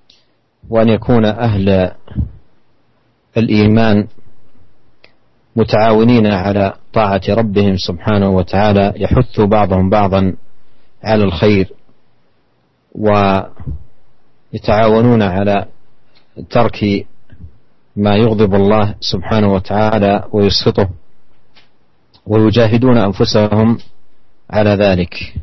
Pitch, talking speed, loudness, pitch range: 105 Hz, 65 wpm, -13 LUFS, 100-110 Hz